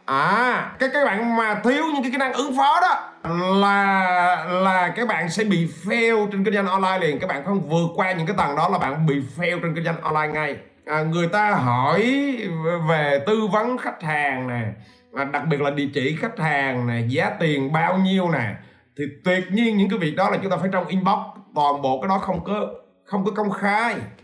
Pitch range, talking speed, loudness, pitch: 150-210 Hz, 225 wpm, -21 LUFS, 180 Hz